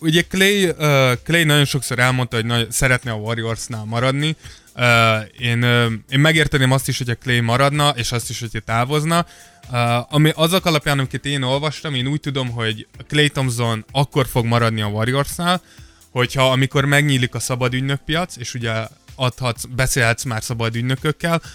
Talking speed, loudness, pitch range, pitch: 165 wpm, -18 LUFS, 120-145 Hz, 130 Hz